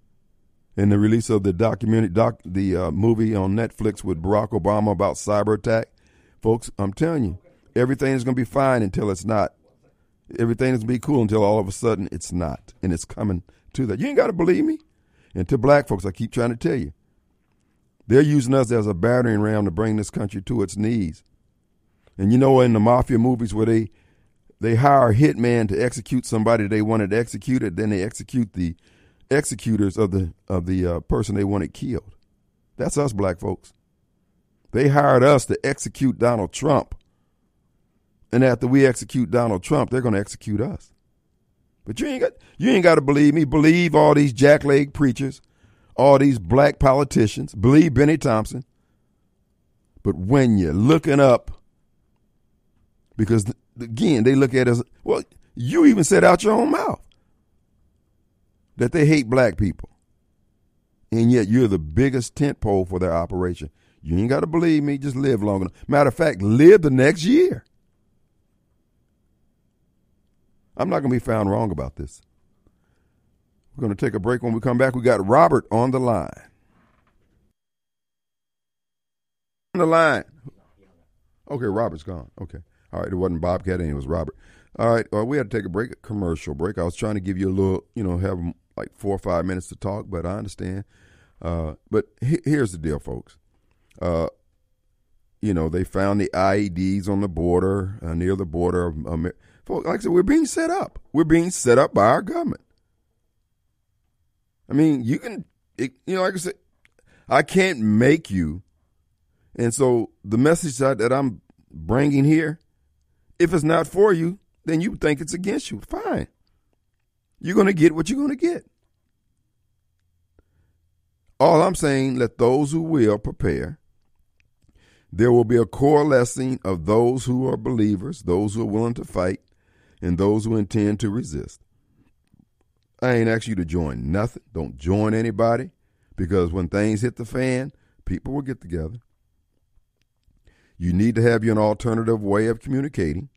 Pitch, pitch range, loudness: 110 Hz, 95-135 Hz, -20 LUFS